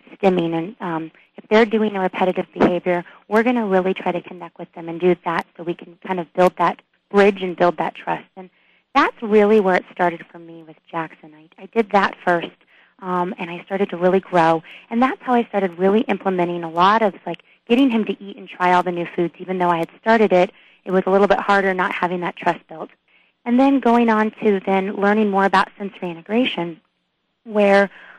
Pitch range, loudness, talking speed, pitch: 175-205 Hz, -19 LUFS, 225 wpm, 185 Hz